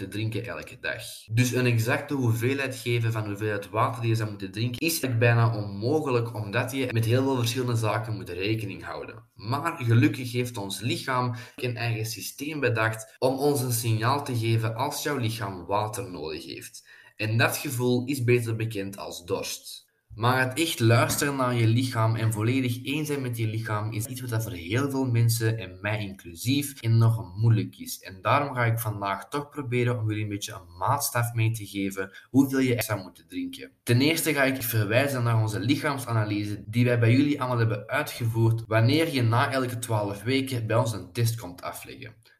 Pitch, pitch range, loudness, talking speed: 120 Hz, 110-130 Hz, -26 LUFS, 190 wpm